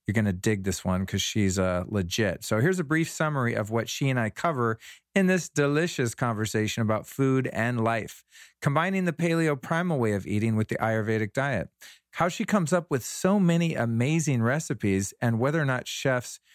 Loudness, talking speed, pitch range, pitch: -26 LUFS, 195 wpm, 110-160 Hz, 120 Hz